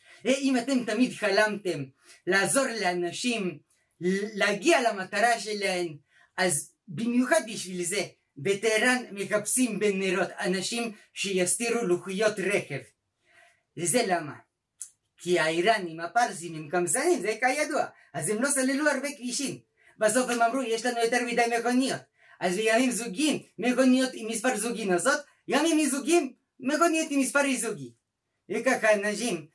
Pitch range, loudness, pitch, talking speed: 185-255 Hz, -27 LUFS, 220 Hz, 120 wpm